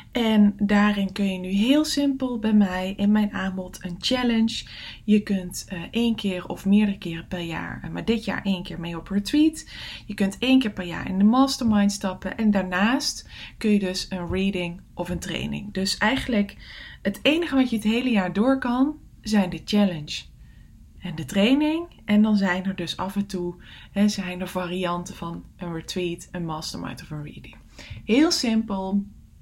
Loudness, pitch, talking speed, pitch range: -24 LUFS, 200 Hz, 185 wpm, 180-225 Hz